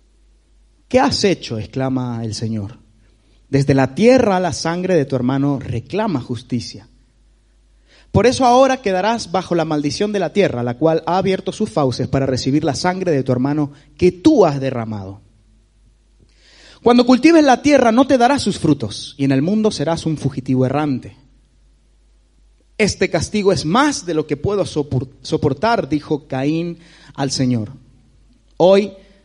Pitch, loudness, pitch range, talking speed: 145 Hz, -17 LUFS, 125-185 Hz, 150 wpm